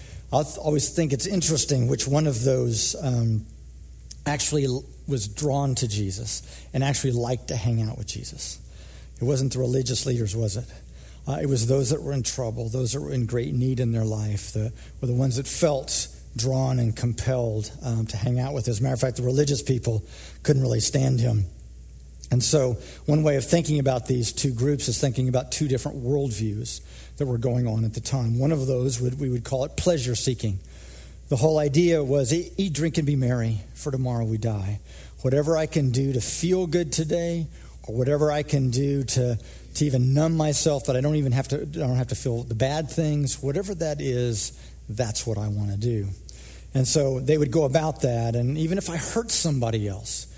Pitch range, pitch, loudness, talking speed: 110-145 Hz, 130 Hz, -25 LUFS, 210 wpm